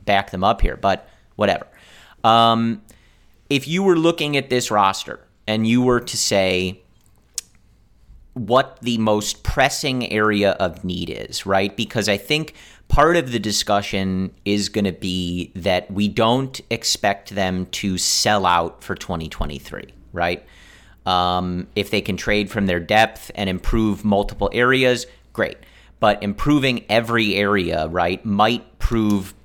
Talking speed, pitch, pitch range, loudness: 145 wpm, 100 Hz, 95-115 Hz, -20 LUFS